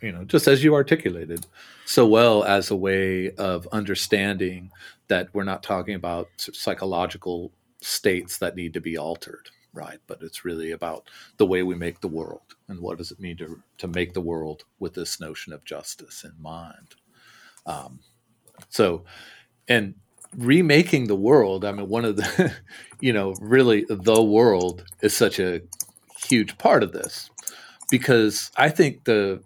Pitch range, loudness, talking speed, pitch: 85-110 Hz, -22 LUFS, 165 wpm, 95 Hz